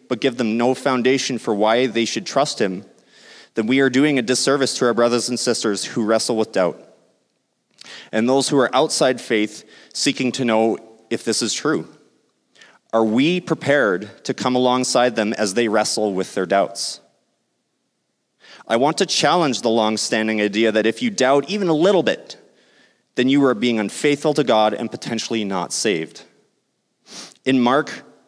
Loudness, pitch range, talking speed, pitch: -19 LUFS, 110-135 Hz, 170 wpm, 120 Hz